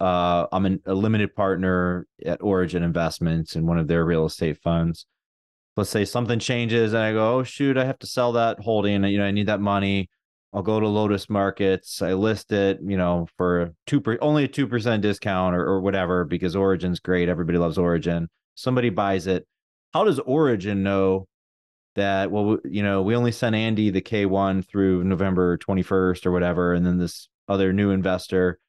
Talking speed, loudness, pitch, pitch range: 195 wpm, -23 LUFS, 95 Hz, 90-105 Hz